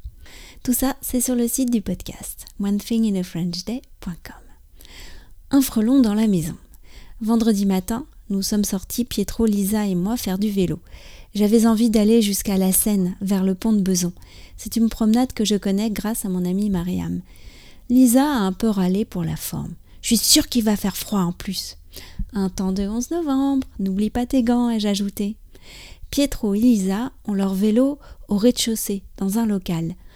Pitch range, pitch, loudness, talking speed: 190-230 Hz, 210 Hz, -21 LUFS, 180 wpm